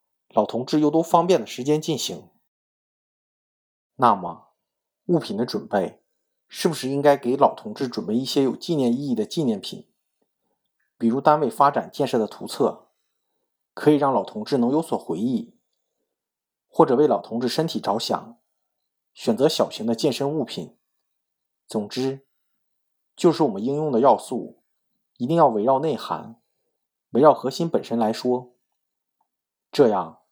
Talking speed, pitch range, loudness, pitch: 220 characters per minute, 120-170 Hz, -22 LUFS, 140 Hz